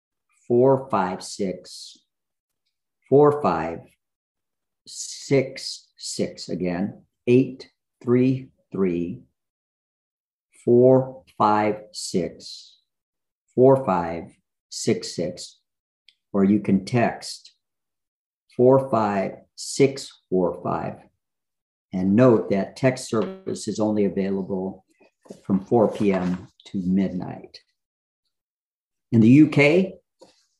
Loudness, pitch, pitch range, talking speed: -22 LUFS, 105 Hz, 95-130 Hz, 85 wpm